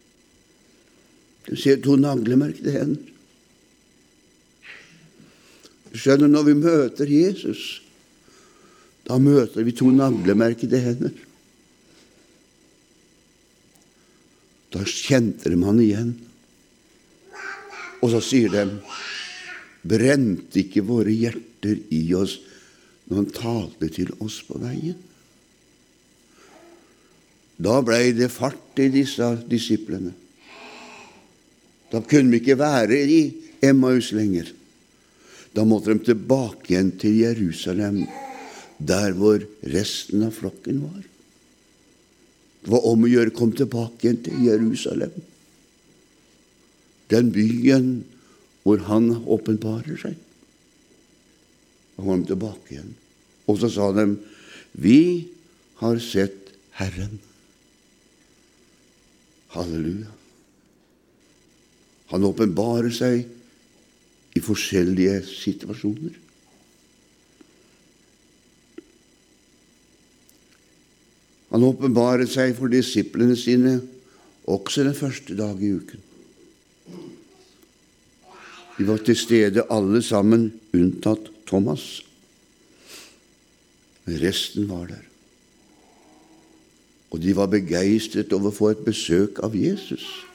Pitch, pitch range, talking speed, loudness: 115 Hz, 105-130 Hz, 90 wpm, -21 LUFS